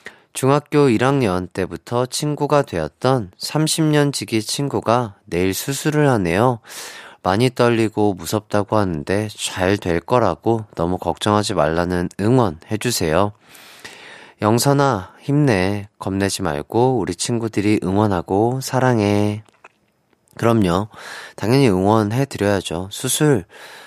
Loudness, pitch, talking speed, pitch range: -19 LUFS, 105 Hz, 245 characters per minute, 95-130 Hz